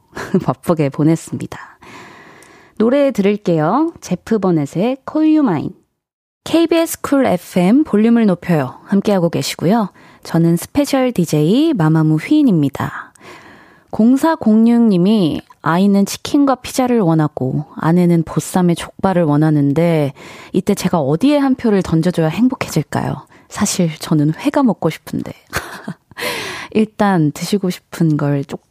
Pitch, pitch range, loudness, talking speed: 185 Hz, 160-245 Hz, -15 LUFS, 275 characters per minute